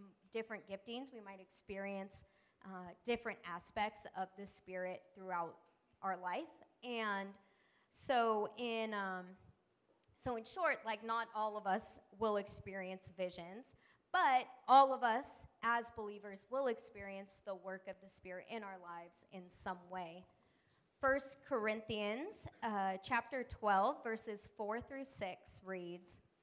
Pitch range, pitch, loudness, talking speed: 190-230 Hz, 205 Hz, -41 LUFS, 130 wpm